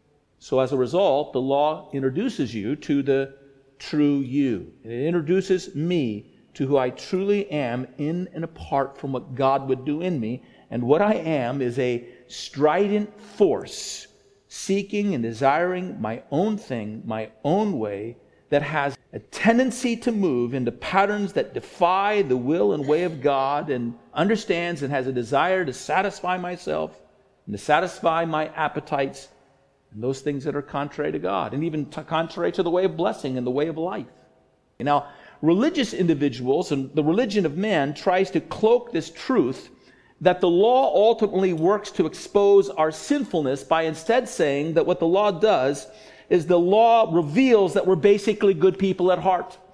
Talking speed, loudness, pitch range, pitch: 165 wpm, -23 LUFS, 135-190 Hz, 160 Hz